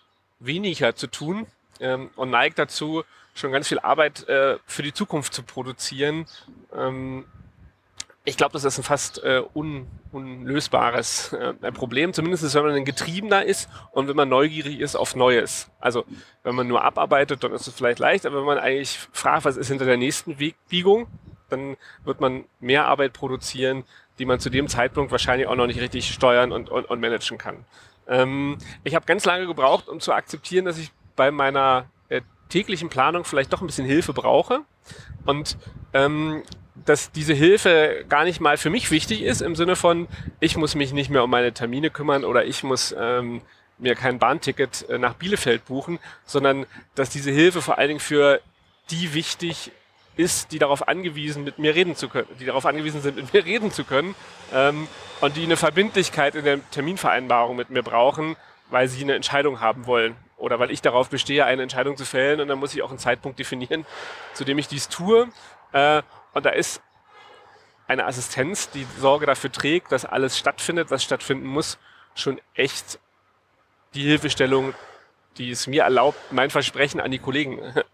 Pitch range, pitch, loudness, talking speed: 130-160 Hz, 140 Hz, -22 LUFS, 180 wpm